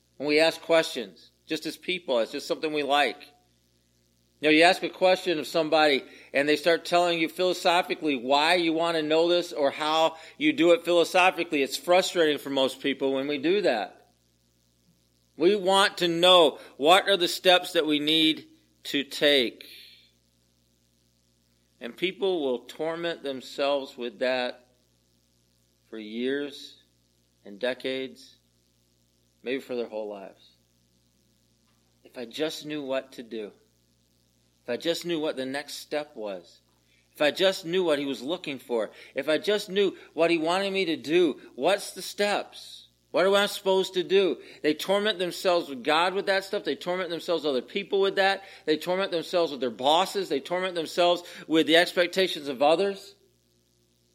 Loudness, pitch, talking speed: -25 LUFS, 150 Hz, 165 wpm